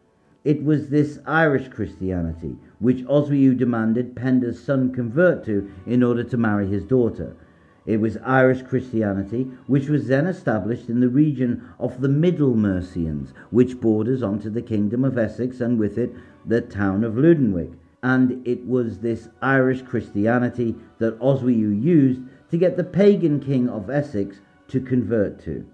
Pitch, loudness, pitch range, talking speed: 125 Hz, -21 LUFS, 110-130 Hz, 155 wpm